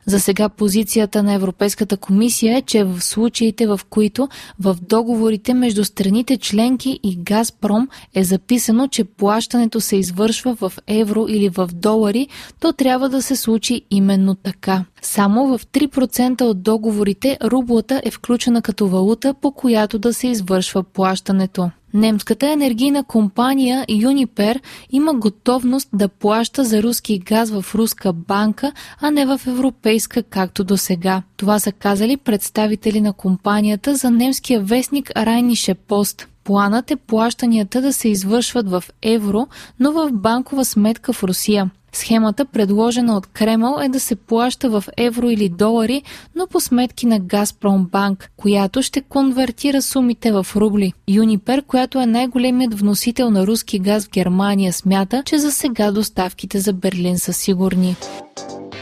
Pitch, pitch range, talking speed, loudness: 220 Hz, 200-250 Hz, 145 wpm, -17 LUFS